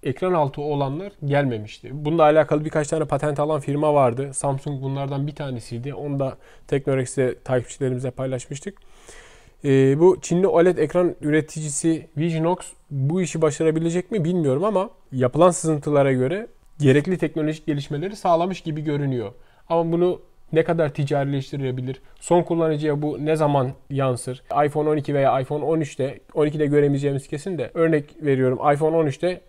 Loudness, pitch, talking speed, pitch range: -22 LUFS, 150 Hz, 135 wpm, 135-160 Hz